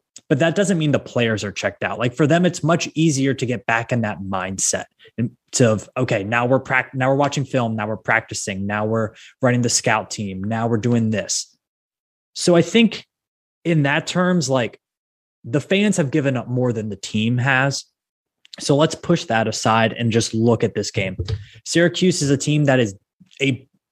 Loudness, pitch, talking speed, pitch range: -20 LUFS, 125 Hz, 200 wpm, 110-150 Hz